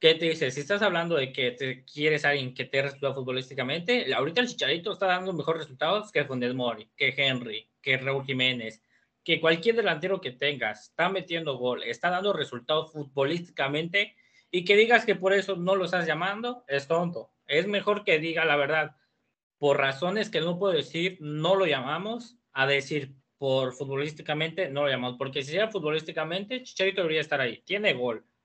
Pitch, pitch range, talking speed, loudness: 155 Hz, 135-190 Hz, 185 wpm, -27 LUFS